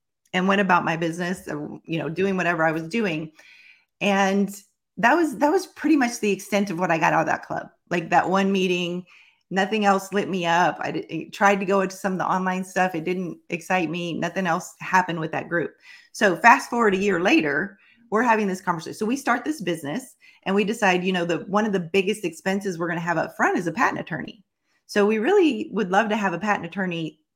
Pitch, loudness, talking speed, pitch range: 190 Hz, -23 LUFS, 230 wpm, 175-210 Hz